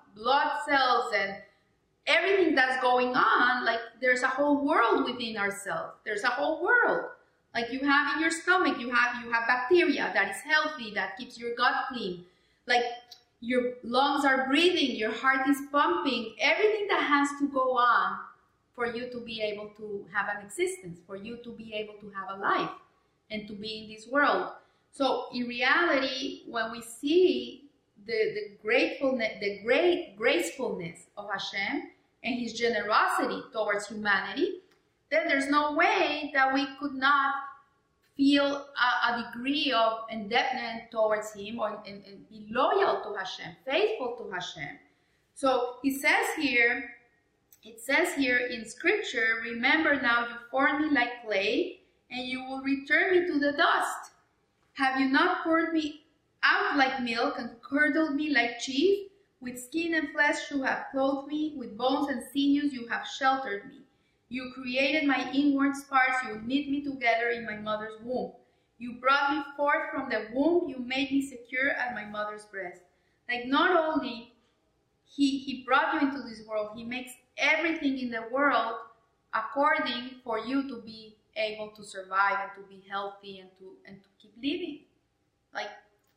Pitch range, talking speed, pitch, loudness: 225-290 Hz, 165 wpm, 260 Hz, -28 LUFS